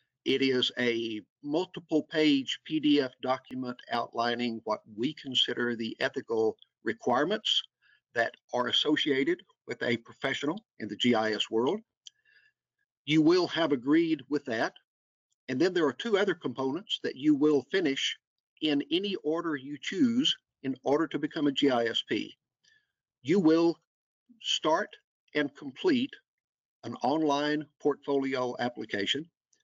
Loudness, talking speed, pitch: -29 LUFS, 125 wpm, 150 Hz